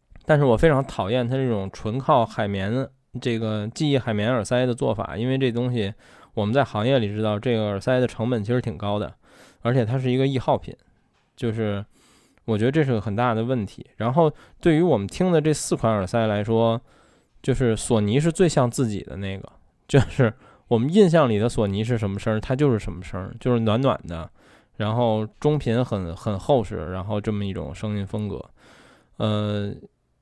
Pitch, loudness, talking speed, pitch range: 115 Hz, -23 LUFS, 285 characters per minute, 105-130 Hz